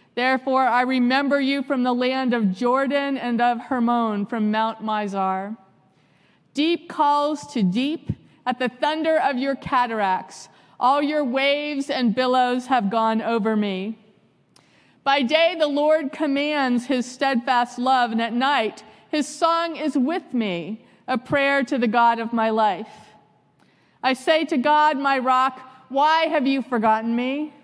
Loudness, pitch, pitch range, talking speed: -21 LUFS, 255 Hz, 225-280 Hz, 150 wpm